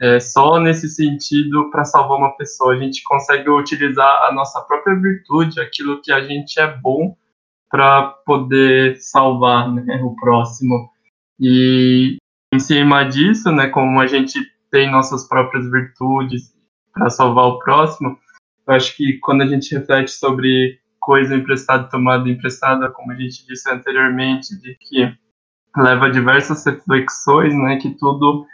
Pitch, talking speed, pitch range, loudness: 135 Hz, 145 wpm, 130-145 Hz, -15 LUFS